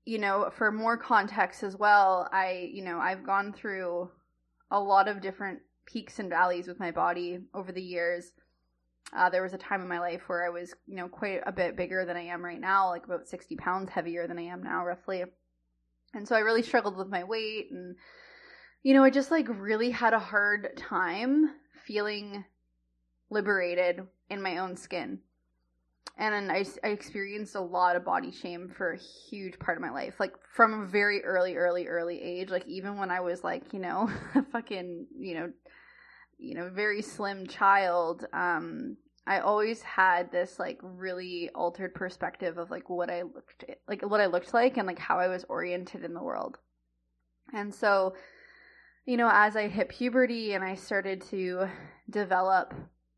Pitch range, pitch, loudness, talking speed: 175-205 Hz, 185 Hz, -30 LUFS, 185 wpm